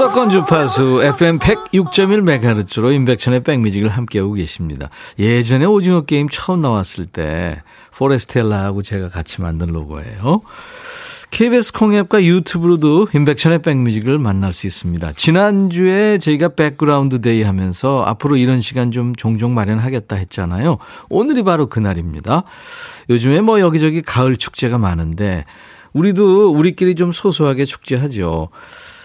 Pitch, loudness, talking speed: 135 Hz, -15 LUFS, 335 characters per minute